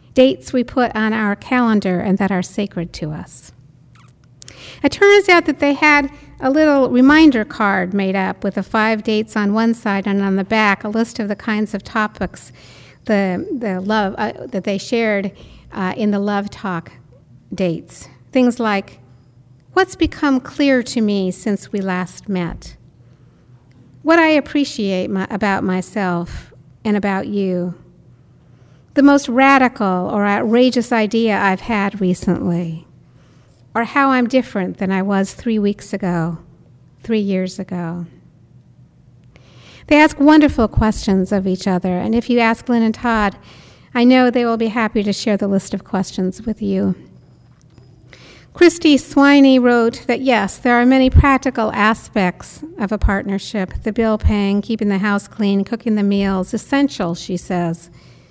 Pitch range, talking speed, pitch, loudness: 185-240 Hz, 155 wpm, 205 Hz, -16 LUFS